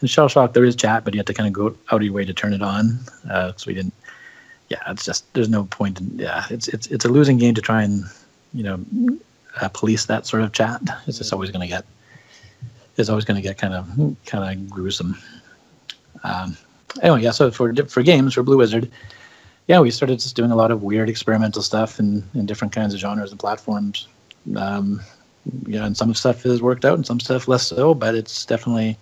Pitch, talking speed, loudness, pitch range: 110 Hz, 235 wpm, -20 LUFS, 105-125 Hz